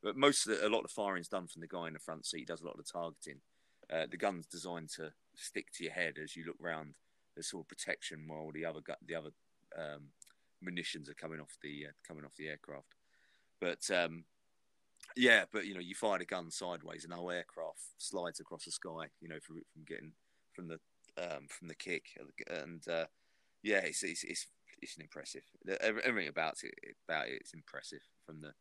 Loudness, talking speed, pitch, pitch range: -39 LUFS, 225 wpm, 80 Hz, 80-85 Hz